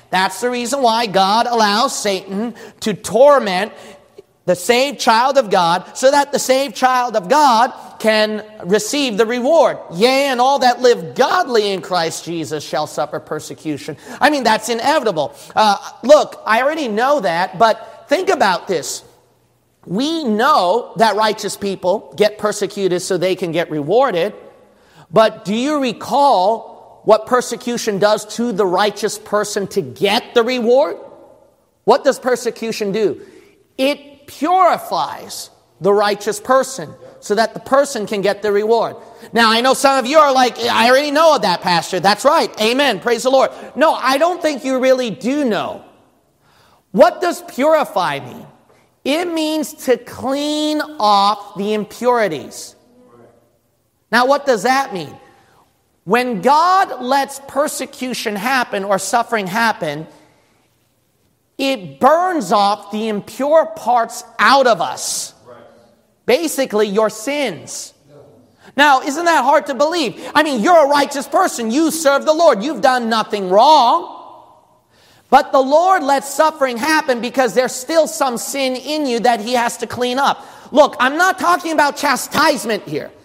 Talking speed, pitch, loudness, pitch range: 150 wpm, 240 Hz, -15 LUFS, 205-280 Hz